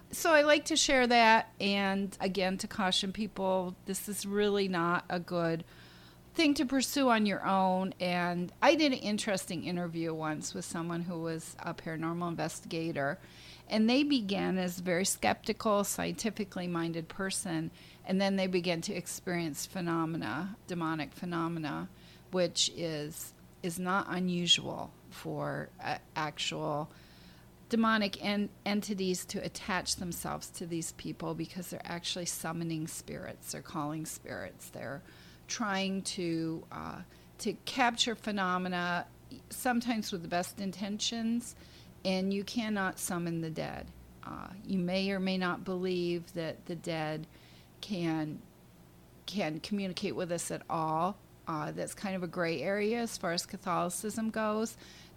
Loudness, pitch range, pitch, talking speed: -33 LUFS, 165-200 Hz, 180 Hz, 140 wpm